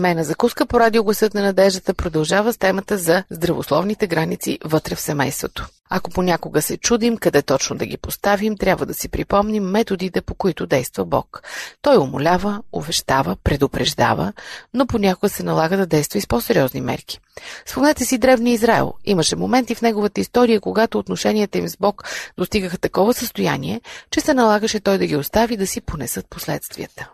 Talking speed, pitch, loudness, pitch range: 165 wpm, 200 Hz, -19 LUFS, 175-230 Hz